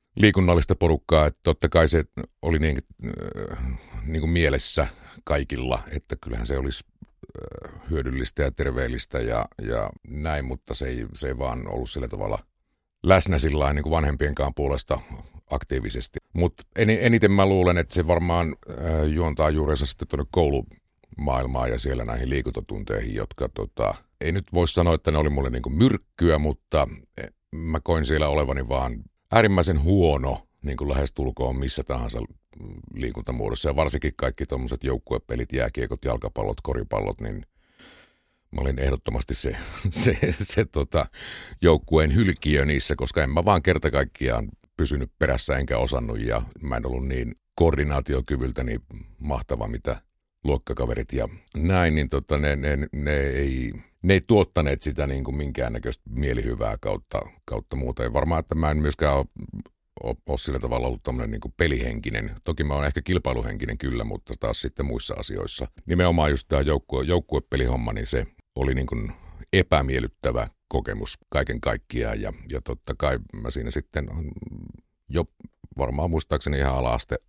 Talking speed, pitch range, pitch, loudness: 145 wpm, 65-85 Hz, 75 Hz, -25 LUFS